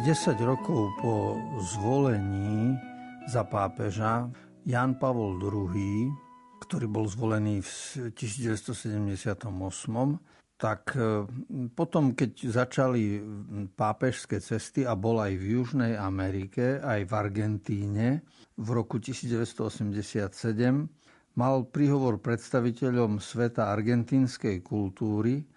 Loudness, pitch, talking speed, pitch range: -30 LUFS, 115 Hz, 90 wpm, 105-130 Hz